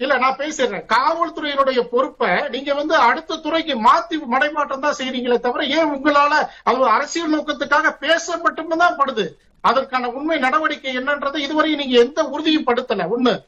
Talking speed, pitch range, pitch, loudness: 140 wpm, 255-310 Hz, 290 Hz, -18 LUFS